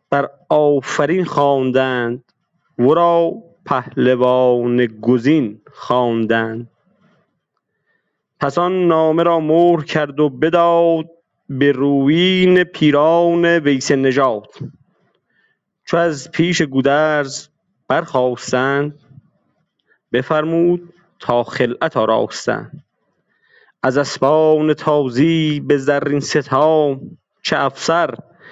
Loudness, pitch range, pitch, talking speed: -16 LUFS, 130-165 Hz, 150 Hz, 80 wpm